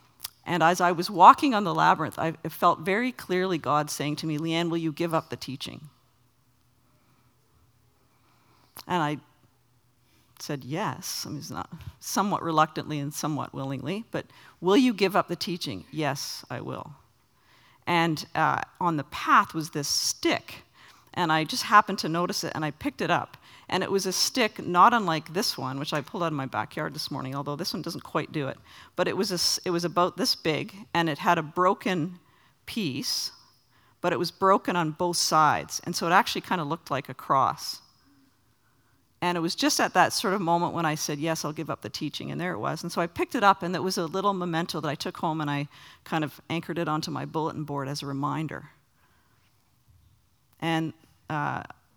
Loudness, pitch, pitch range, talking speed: -26 LUFS, 160 Hz, 140-175 Hz, 205 wpm